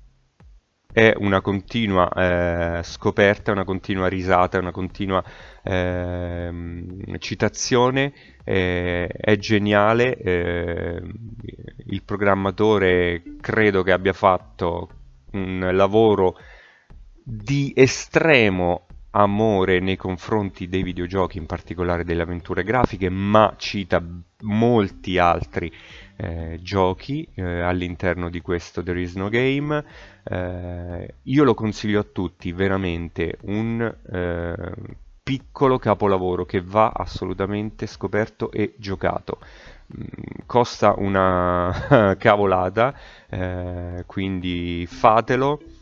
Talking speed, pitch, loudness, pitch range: 95 wpm, 95 Hz, -21 LUFS, 90-110 Hz